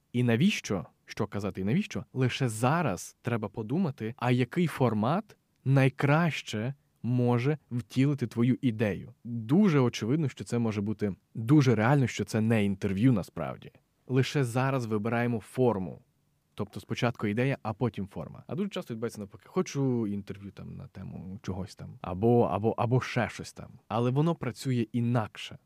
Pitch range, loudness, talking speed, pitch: 110-135 Hz, -29 LUFS, 145 wpm, 120 Hz